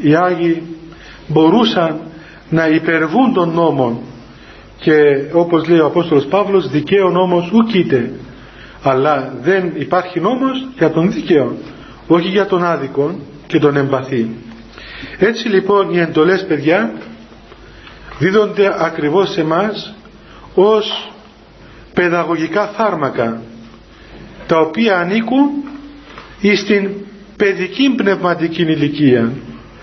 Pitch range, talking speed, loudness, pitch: 140-195 Hz, 100 wpm, -14 LUFS, 170 Hz